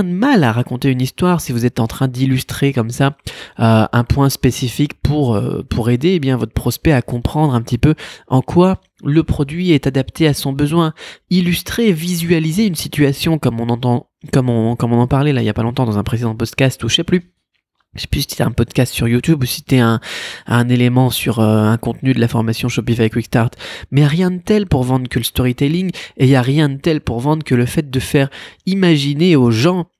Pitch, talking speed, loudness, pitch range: 135 Hz, 240 wpm, -15 LUFS, 120-160 Hz